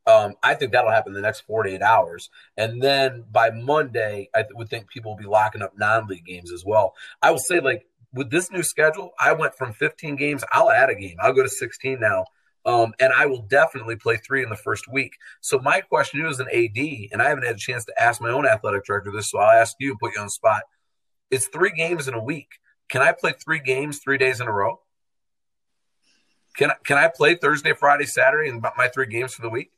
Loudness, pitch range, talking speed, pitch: -21 LUFS, 115-150 Hz, 245 wpm, 130 Hz